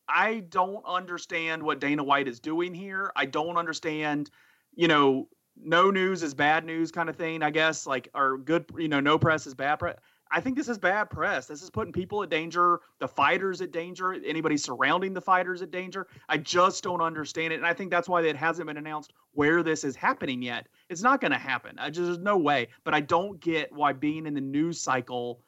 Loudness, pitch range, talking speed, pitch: -27 LUFS, 150-180 Hz, 225 wpm, 165 Hz